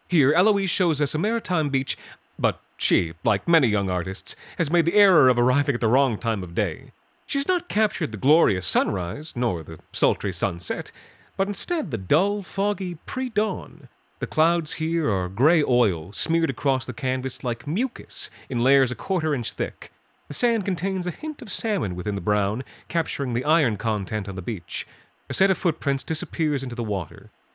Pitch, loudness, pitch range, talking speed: 140 Hz, -24 LUFS, 115-180 Hz, 185 wpm